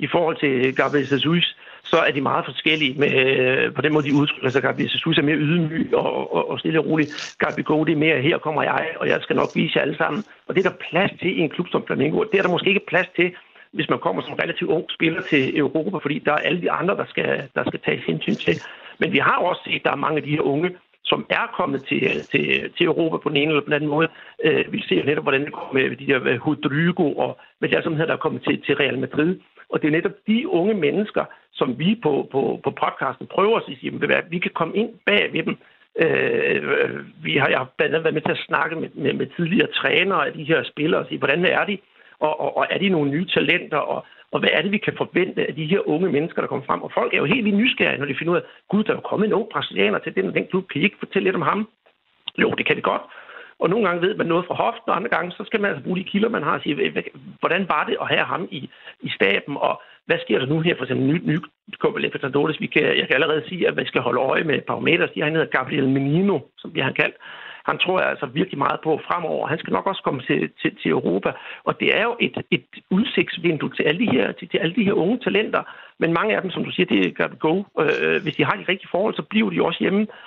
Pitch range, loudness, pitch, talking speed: 150-205 Hz, -21 LUFS, 170 Hz, 275 wpm